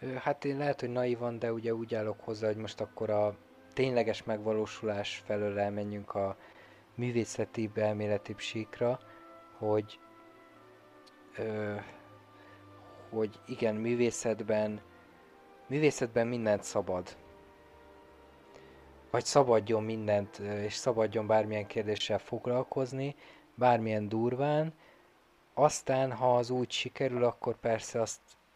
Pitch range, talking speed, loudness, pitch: 105-120 Hz, 100 wpm, -33 LUFS, 110 Hz